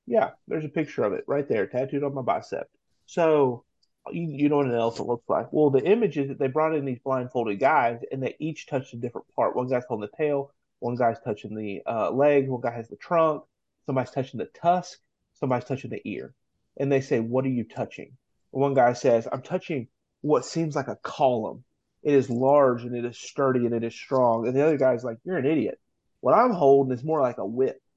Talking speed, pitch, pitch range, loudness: 230 wpm, 135 Hz, 120-150 Hz, -25 LUFS